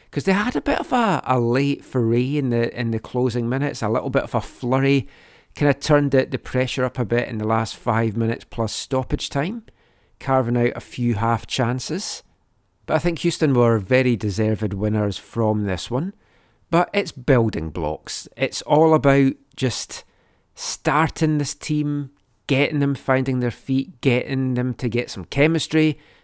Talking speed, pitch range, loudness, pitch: 180 wpm, 115-145 Hz, -21 LUFS, 130 Hz